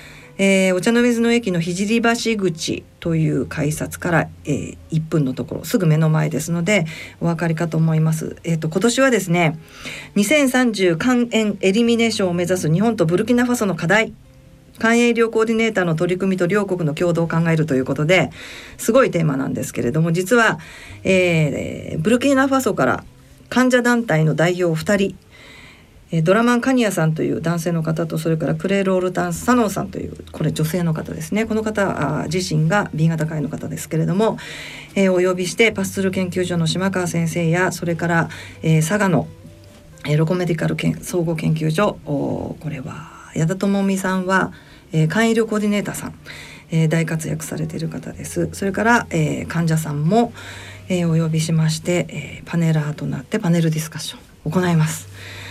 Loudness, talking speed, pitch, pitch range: -19 LUFS, 370 characters per minute, 170 Hz, 155-200 Hz